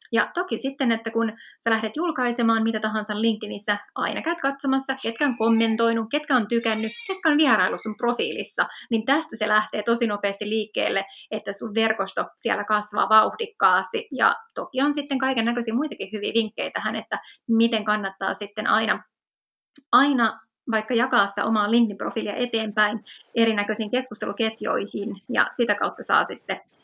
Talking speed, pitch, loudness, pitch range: 150 wpm, 225 Hz, -24 LUFS, 215-255 Hz